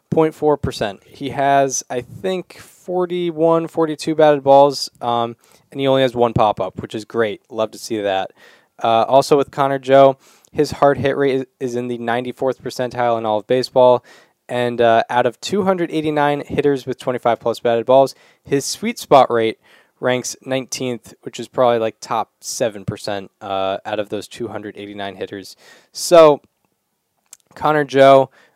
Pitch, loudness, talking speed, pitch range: 130 Hz, -17 LUFS, 150 wpm, 115-140 Hz